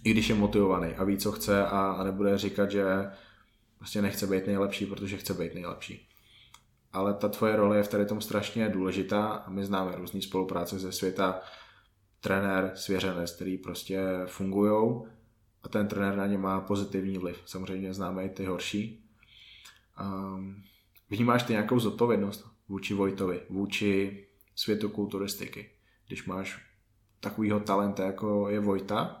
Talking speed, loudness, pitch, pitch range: 145 wpm, -30 LUFS, 100 Hz, 95-105 Hz